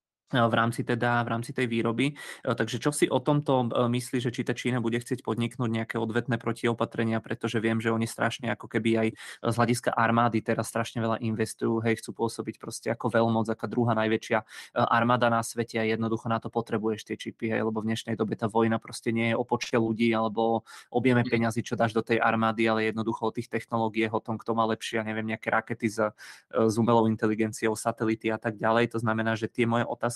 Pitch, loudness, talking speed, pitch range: 115 Hz, -28 LUFS, 210 wpm, 110-120 Hz